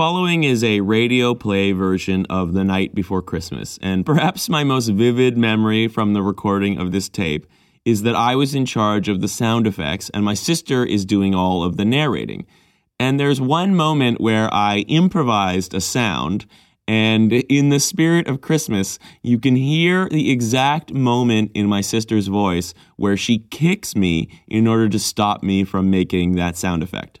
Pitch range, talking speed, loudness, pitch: 95-130 Hz, 180 wpm, -18 LUFS, 110 Hz